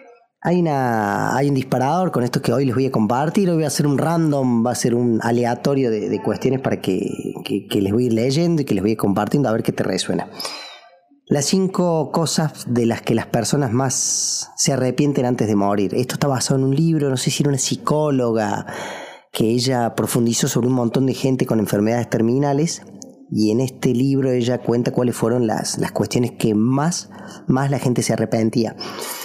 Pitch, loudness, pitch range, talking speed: 130 Hz, -19 LUFS, 115-145 Hz, 210 wpm